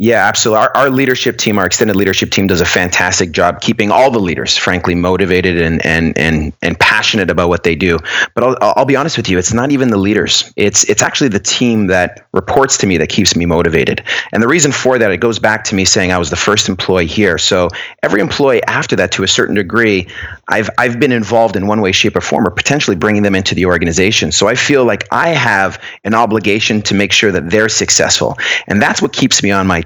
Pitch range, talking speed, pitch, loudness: 90-110 Hz, 235 wpm, 100 Hz, -11 LUFS